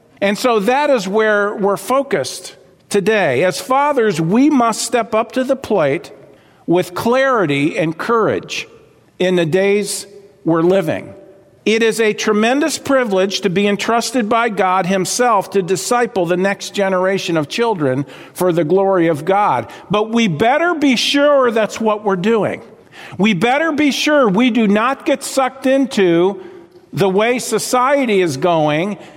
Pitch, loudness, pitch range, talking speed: 215 Hz, -15 LUFS, 190-250 Hz, 150 wpm